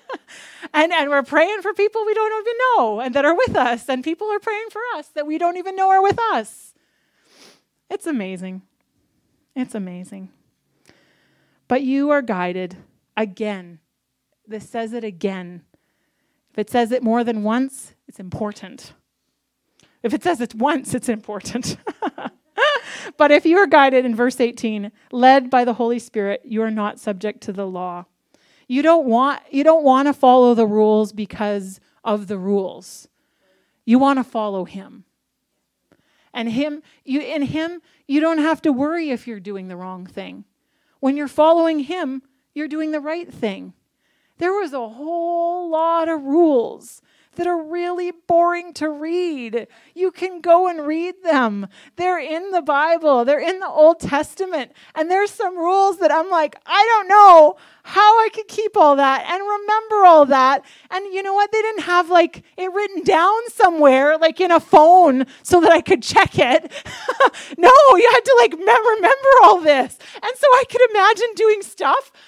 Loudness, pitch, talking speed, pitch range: -17 LUFS, 305 Hz, 170 wpm, 240-360 Hz